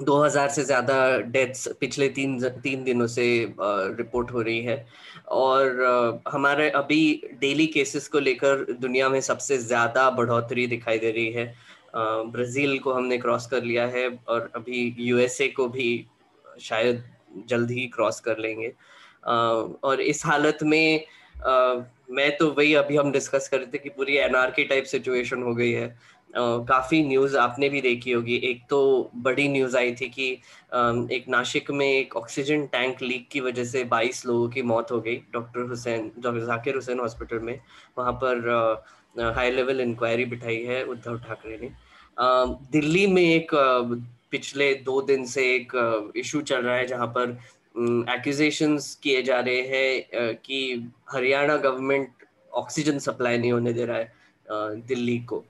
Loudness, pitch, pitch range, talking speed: -24 LUFS, 125 Hz, 120-135 Hz, 165 wpm